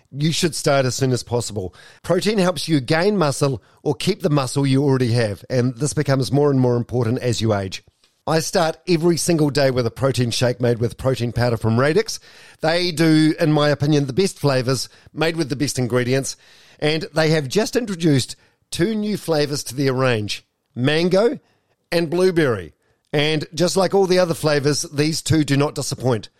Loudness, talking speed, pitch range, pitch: -19 LUFS, 190 wpm, 125-165 Hz, 145 Hz